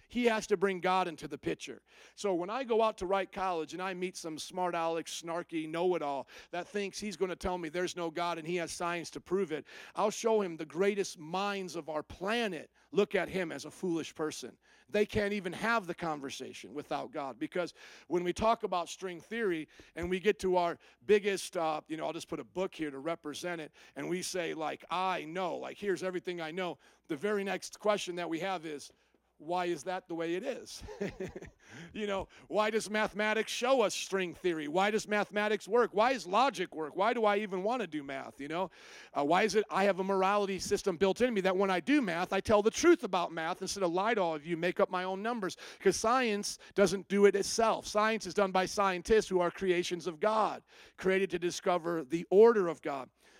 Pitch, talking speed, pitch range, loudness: 185 Hz, 230 wpm, 170-205 Hz, -33 LUFS